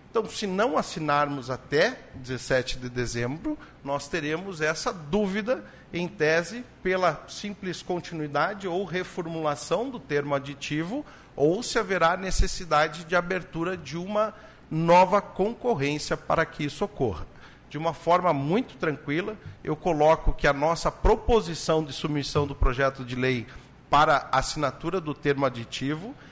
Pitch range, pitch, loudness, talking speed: 145-185 Hz, 160 Hz, -27 LUFS, 130 wpm